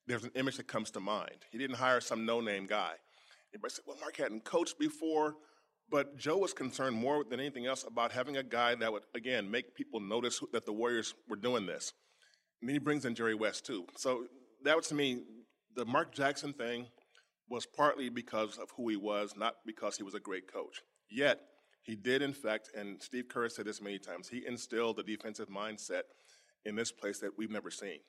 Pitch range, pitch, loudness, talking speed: 110-140 Hz, 120 Hz, -37 LUFS, 210 wpm